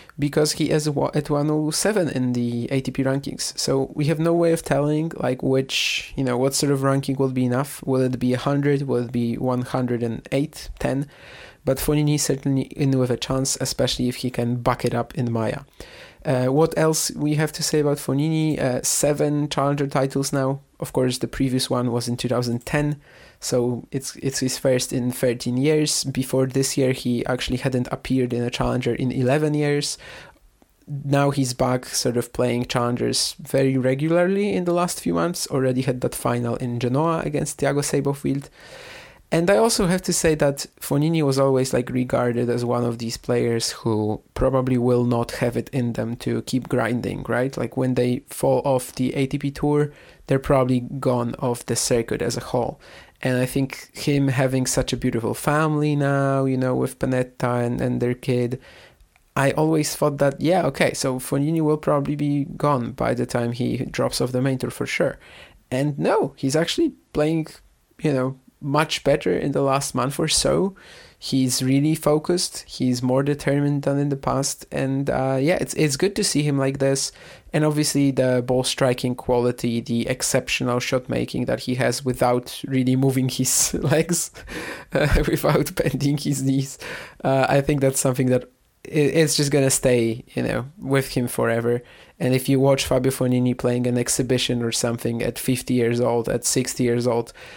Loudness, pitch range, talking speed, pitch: -22 LUFS, 125-145 Hz, 185 wpm, 135 Hz